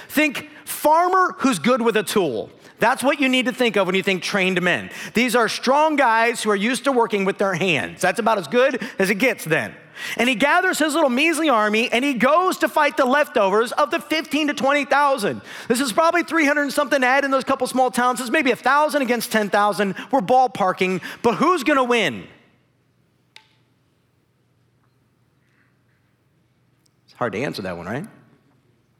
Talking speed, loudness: 185 wpm, -19 LUFS